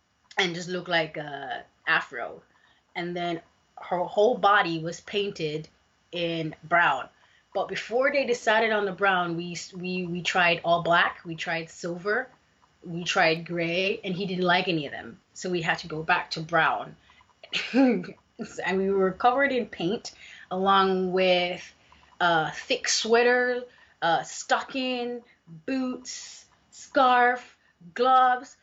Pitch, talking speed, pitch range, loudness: 185 Hz, 140 wpm, 170-235 Hz, -25 LUFS